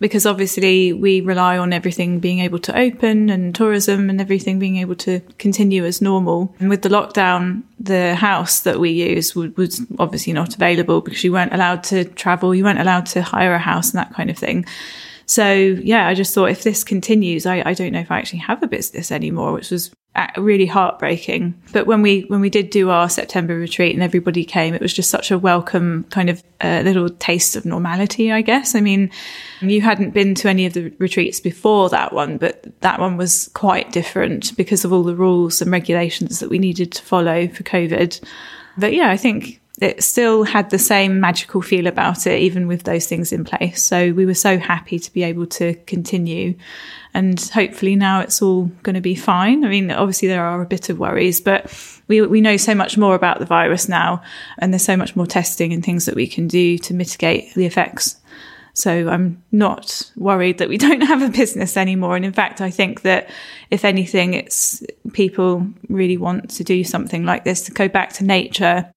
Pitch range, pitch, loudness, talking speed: 180-200 Hz, 185 Hz, -17 LUFS, 210 wpm